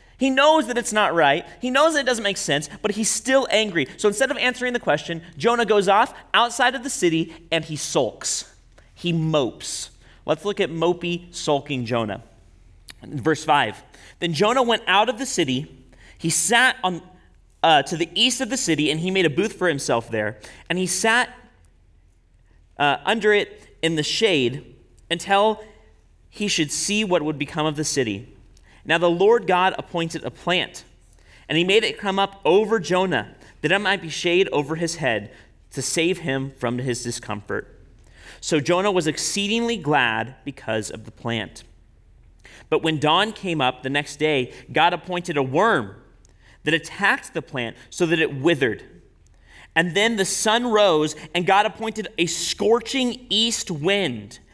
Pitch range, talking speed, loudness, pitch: 130-205 Hz, 175 wpm, -21 LUFS, 170 Hz